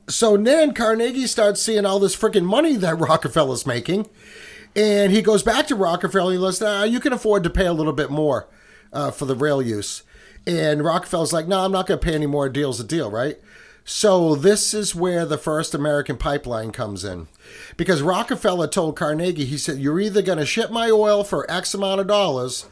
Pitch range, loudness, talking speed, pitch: 150-205 Hz, -20 LUFS, 215 wpm, 180 Hz